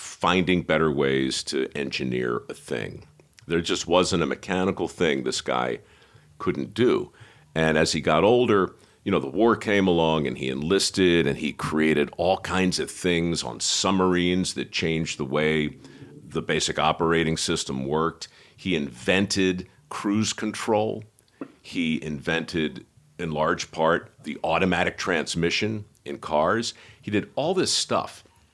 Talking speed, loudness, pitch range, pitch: 145 wpm, -24 LUFS, 75-95 Hz, 85 Hz